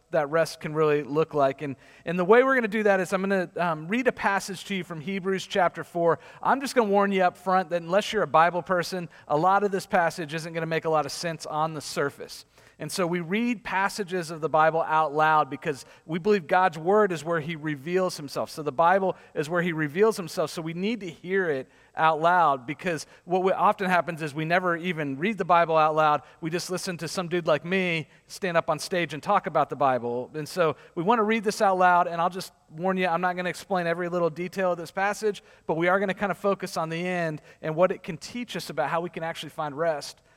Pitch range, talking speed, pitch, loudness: 160-190 Hz, 260 wpm, 175 Hz, -26 LUFS